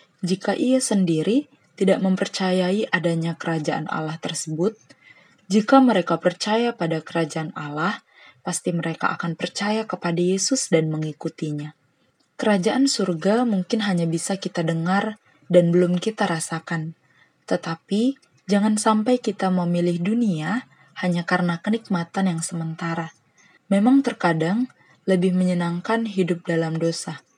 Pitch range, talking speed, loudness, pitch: 165-210 Hz, 115 wpm, -22 LUFS, 180 Hz